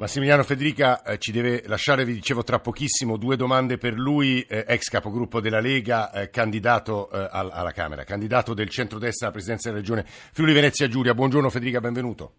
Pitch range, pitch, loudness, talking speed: 110-130 Hz, 120 Hz, -23 LUFS, 185 wpm